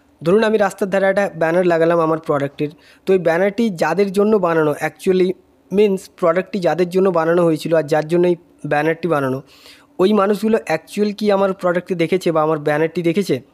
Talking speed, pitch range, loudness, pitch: 175 wpm, 160-195 Hz, -17 LUFS, 175 Hz